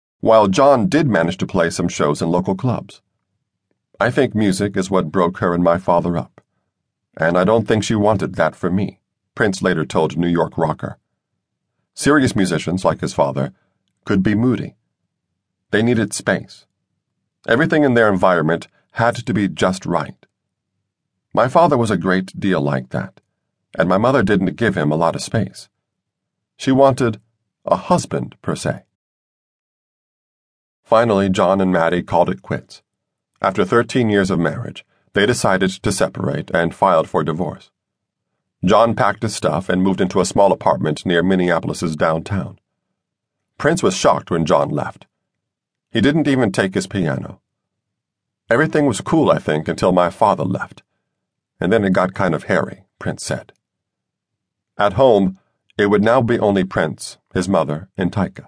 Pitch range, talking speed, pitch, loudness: 85-105 Hz, 160 wpm, 95 Hz, -17 LUFS